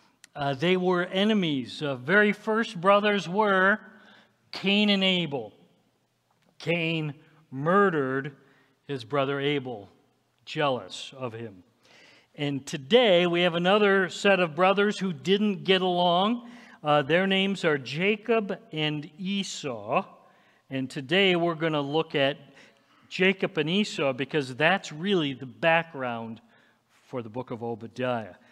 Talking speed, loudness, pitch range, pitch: 125 wpm, -25 LUFS, 140-195 Hz, 170 Hz